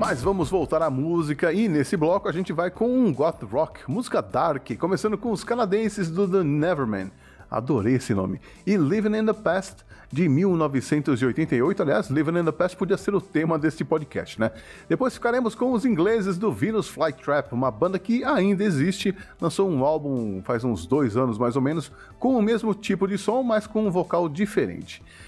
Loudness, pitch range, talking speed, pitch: -24 LUFS, 135-205 Hz, 190 wpm, 170 Hz